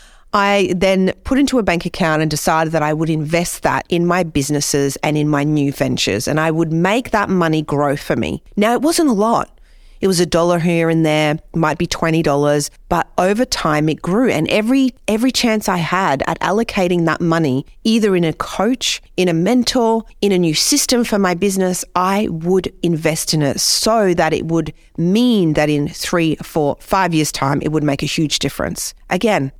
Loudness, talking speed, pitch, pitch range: -16 LUFS, 200 wpm, 170 Hz, 155-200 Hz